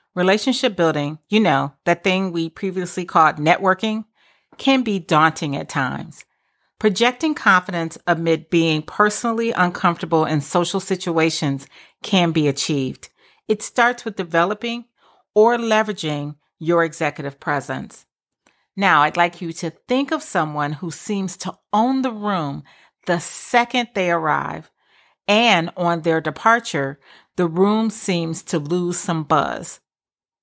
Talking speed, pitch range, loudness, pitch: 130 wpm, 160-215 Hz, -19 LUFS, 175 Hz